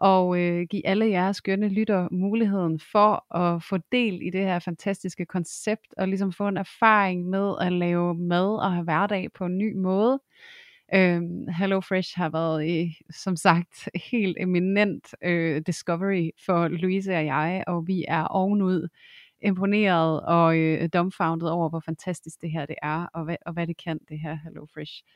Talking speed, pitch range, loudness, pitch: 175 wpm, 165-195 Hz, -25 LUFS, 180 Hz